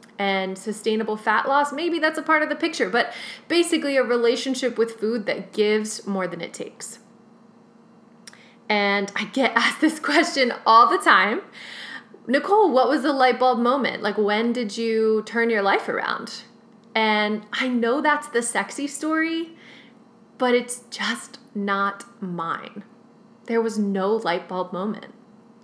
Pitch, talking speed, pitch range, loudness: 230 Hz, 150 wpm, 215-260 Hz, -22 LUFS